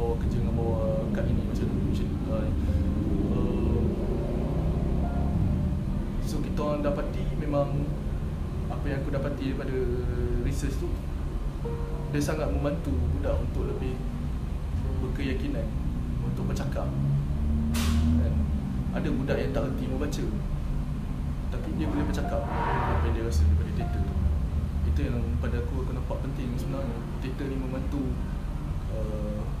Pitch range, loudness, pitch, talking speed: 70-75 Hz, -29 LUFS, 75 Hz, 125 wpm